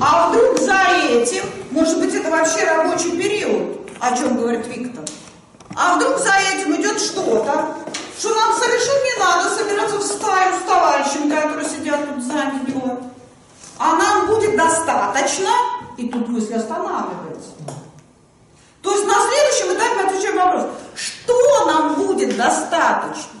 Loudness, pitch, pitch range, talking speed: -17 LUFS, 355 Hz, 290-410 Hz, 140 wpm